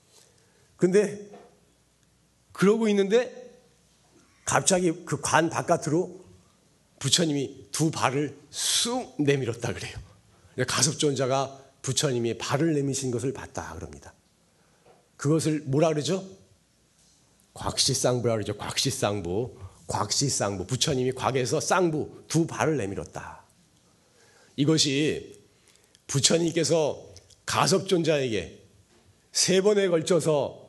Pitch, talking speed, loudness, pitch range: 140 Hz, 225 characters per minute, -25 LUFS, 120-165 Hz